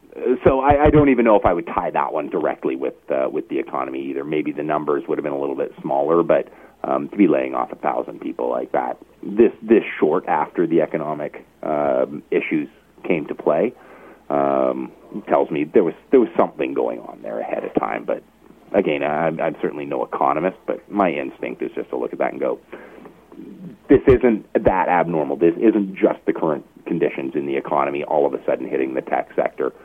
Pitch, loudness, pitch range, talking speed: 75 Hz, -20 LUFS, 70-105 Hz, 210 wpm